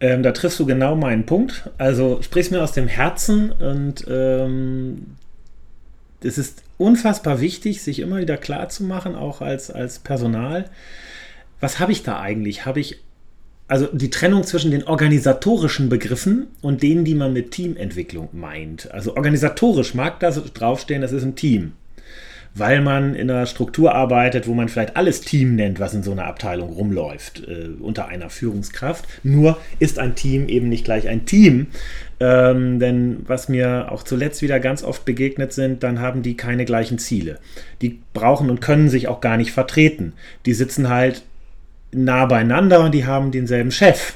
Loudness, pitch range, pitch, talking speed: -19 LUFS, 115-150 Hz, 130 Hz, 165 wpm